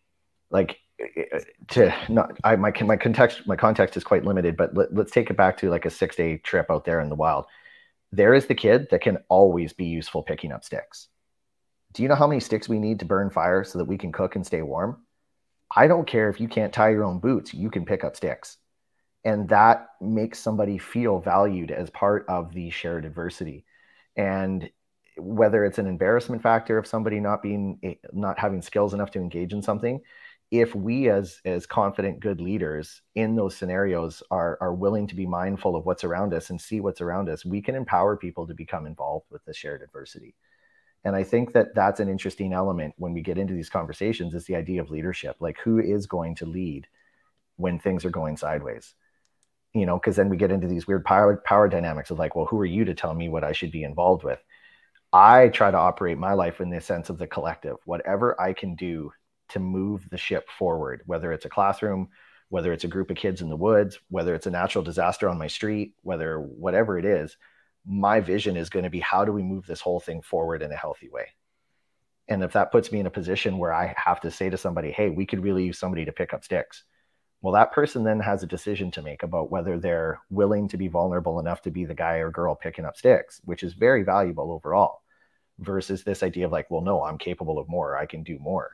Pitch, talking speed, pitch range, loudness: 95 Hz, 225 wpm, 90-105 Hz, -24 LUFS